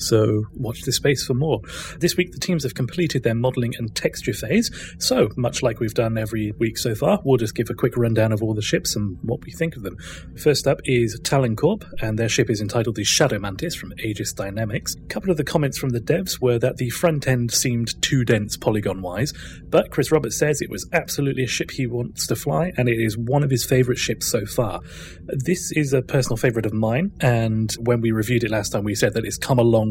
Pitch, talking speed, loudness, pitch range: 120 Hz, 240 wpm, -22 LUFS, 110-135 Hz